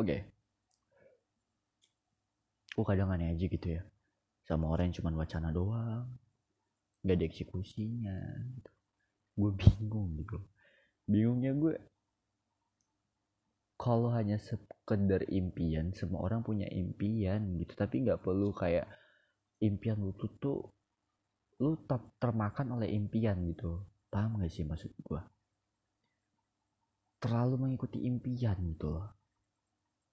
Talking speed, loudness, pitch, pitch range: 110 wpm, -35 LUFS, 105 Hz, 95-110 Hz